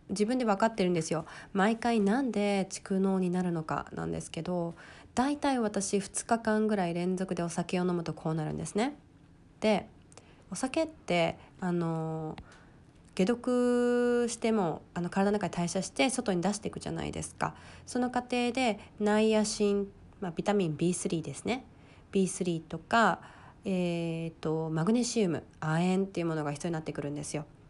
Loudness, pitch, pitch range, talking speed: -31 LUFS, 185 Hz, 165-215 Hz, 325 characters per minute